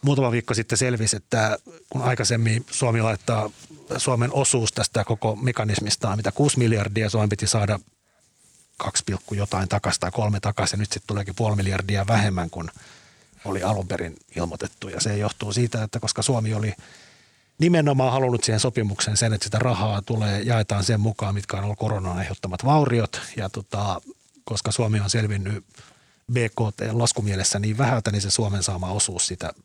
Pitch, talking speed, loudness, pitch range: 110 Hz, 160 wpm, -23 LUFS, 100-120 Hz